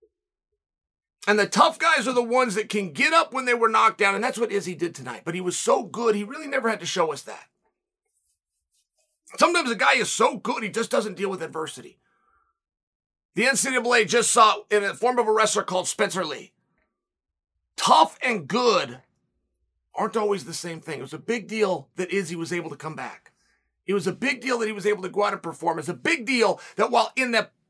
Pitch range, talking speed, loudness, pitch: 175-245 Hz, 225 wpm, -23 LUFS, 210 Hz